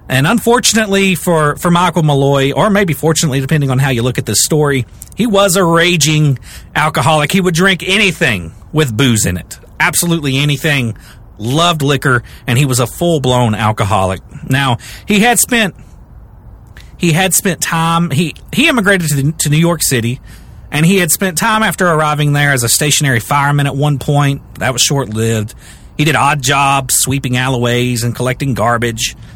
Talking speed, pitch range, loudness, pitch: 175 wpm, 125-170 Hz, -12 LUFS, 145 Hz